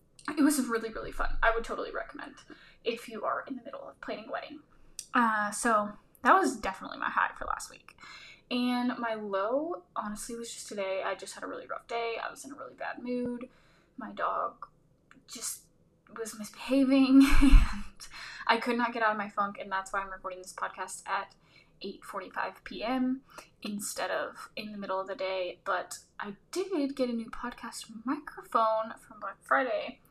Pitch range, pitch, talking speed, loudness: 210-260 Hz, 230 Hz, 190 wpm, -31 LUFS